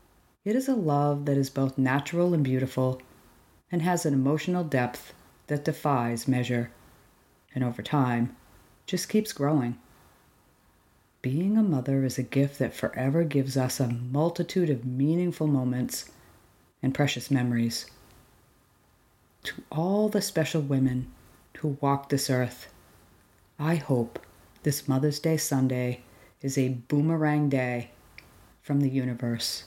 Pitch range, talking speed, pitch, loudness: 125-150 Hz, 130 wpm, 135 Hz, -28 LUFS